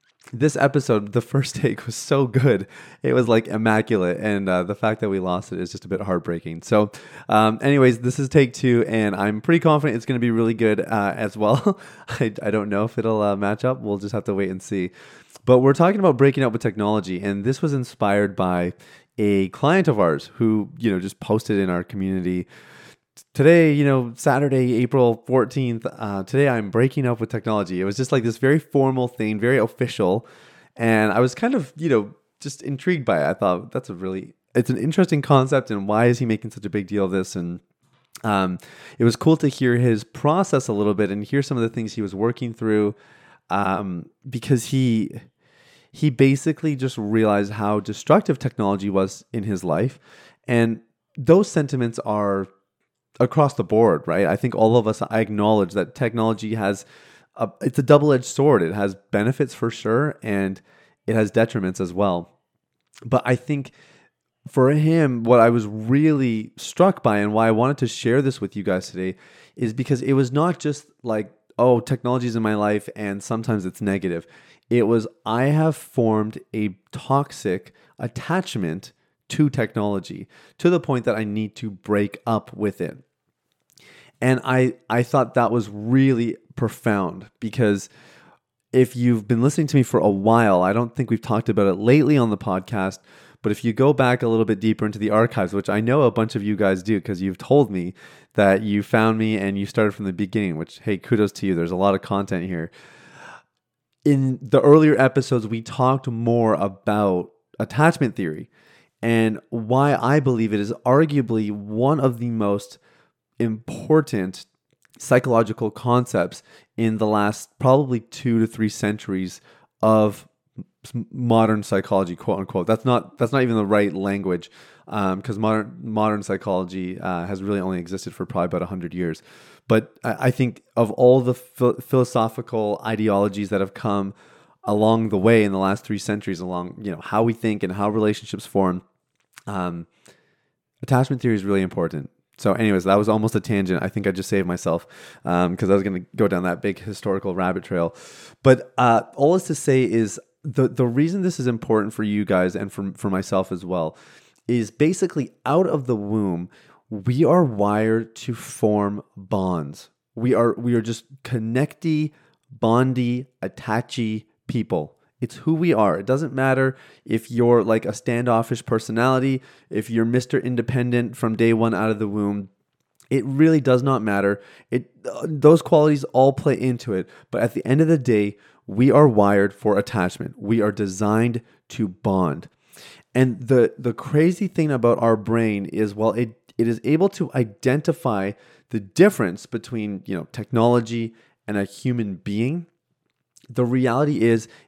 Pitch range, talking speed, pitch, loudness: 100-130 Hz, 180 wpm, 115 Hz, -21 LUFS